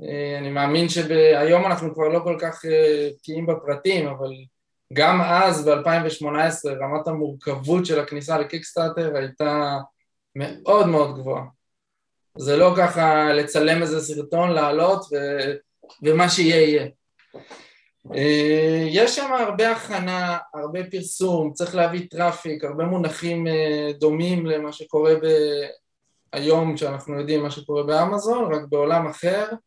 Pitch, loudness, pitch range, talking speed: 155 Hz, -21 LUFS, 150-170 Hz, 125 wpm